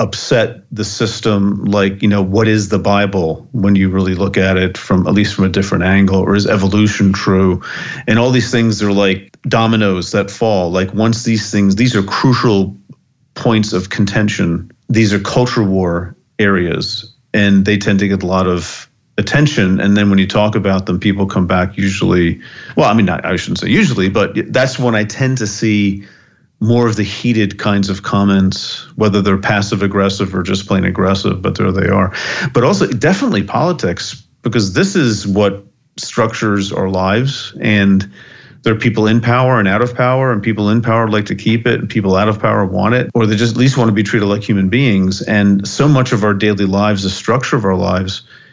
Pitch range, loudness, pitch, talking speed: 95-115 Hz, -14 LUFS, 105 Hz, 205 wpm